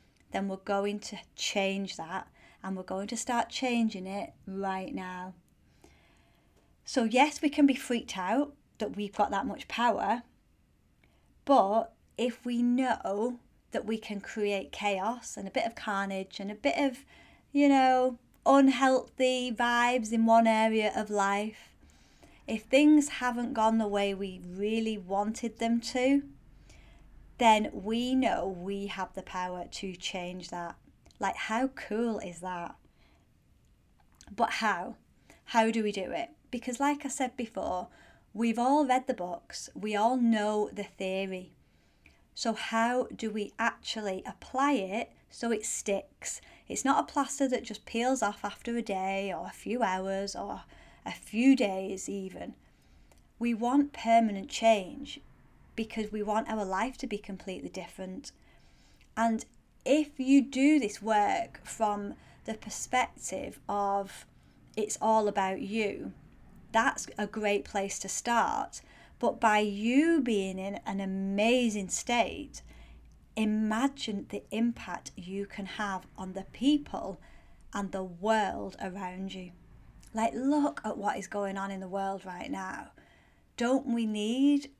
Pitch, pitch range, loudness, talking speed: 215 Hz, 195-240 Hz, -30 LUFS, 145 wpm